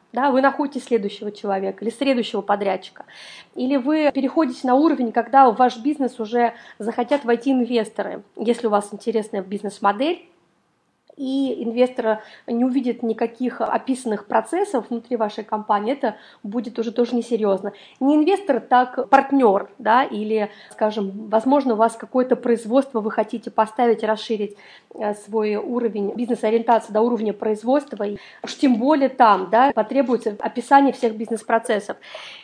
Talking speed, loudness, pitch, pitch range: 135 wpm, -21 LUFS, 235 Hz, 215-255 Hz